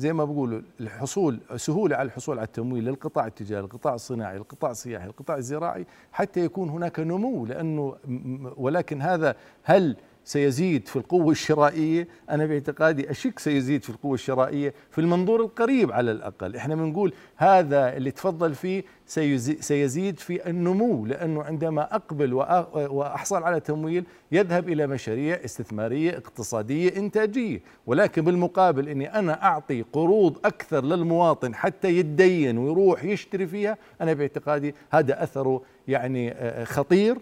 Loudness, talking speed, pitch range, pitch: -25 LUFS, 130 wpm, 135-175 Hz, 150 Hz